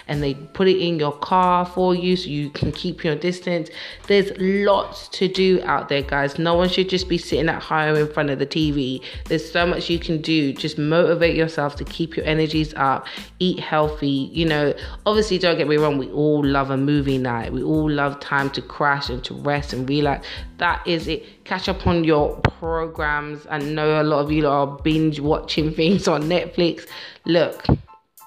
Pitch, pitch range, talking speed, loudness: 155 Hz, 145-175 Hz, 205 wpm, -21 LUFS